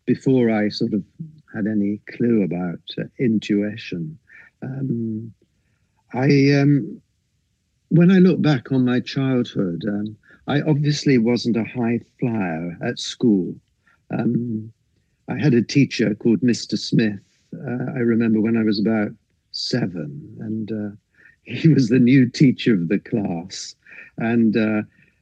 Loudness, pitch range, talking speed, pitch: -20 LUFS, 105-130 Hz, 135 wpm, 115 Hz